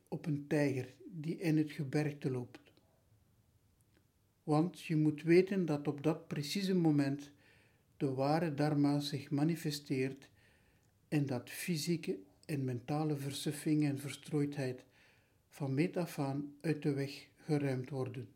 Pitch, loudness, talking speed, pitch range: 145 Hz, -36 LUFS, 130 wpm, 130-155 Hz